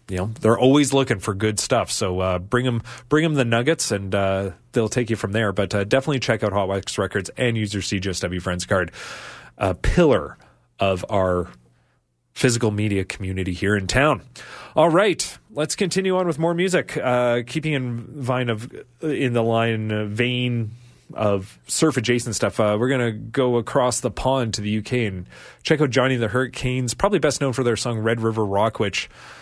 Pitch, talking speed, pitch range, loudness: 115 Hz, 190 wpm, 100-130 Hz, -22 LUFS